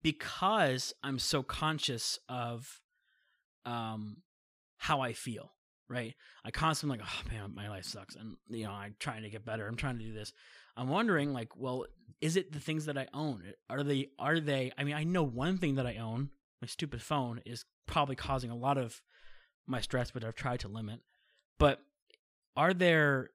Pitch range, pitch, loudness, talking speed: 115-145 Hz, 130 Hz, -35 LUFS, 190 wpm